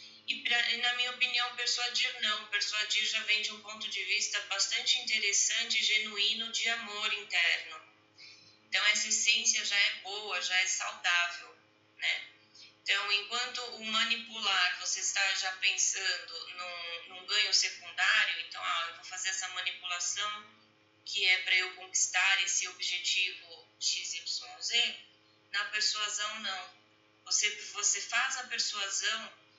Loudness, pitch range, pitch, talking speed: -30 LUFS, 180-220 Hz, 205 Hz, 140 wpm